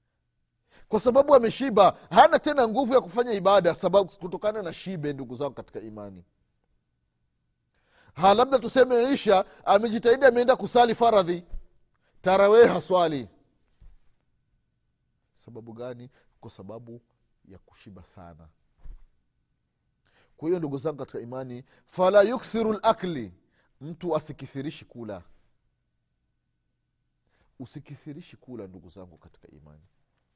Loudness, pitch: -22 LUFS, 145 Hz